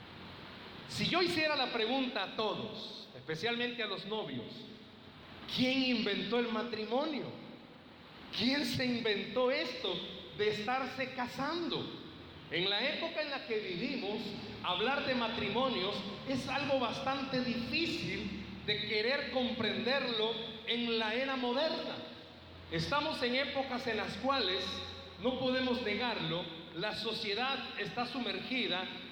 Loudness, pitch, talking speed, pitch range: -35 LUFS, 245 Hz, 115 wpm, 215-265 Hz